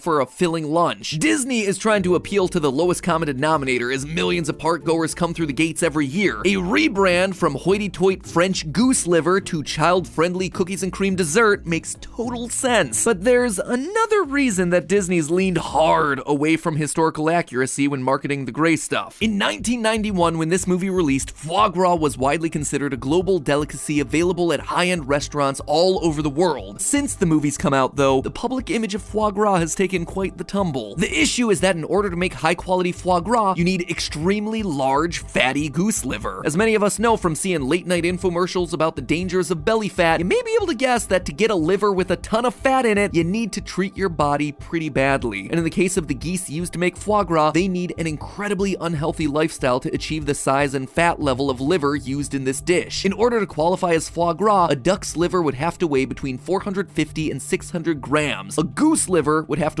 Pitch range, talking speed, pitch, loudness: 155-195 Hz, 220 wpm, 175 Hz, -20 LUFS